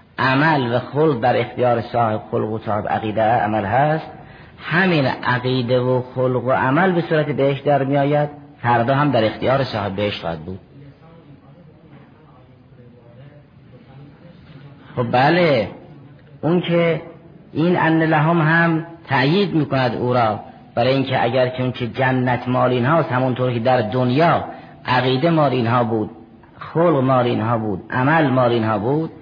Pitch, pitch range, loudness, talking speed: 130 Hz, 125-155 Hz, -18 LUFS, 145 wpm